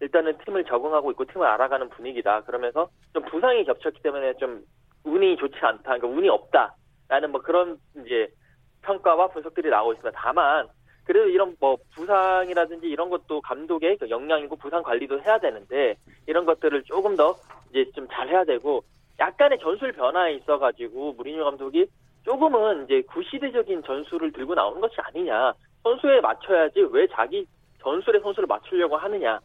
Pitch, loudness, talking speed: 275 Hz, -24 LUFS, 380 characters per minute